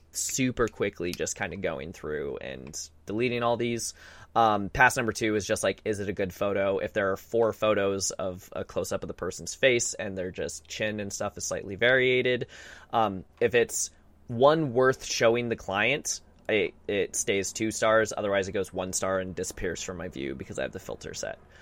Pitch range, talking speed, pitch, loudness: 95-120 Hz, 205 wpm, 110 Hz, -28 LUFS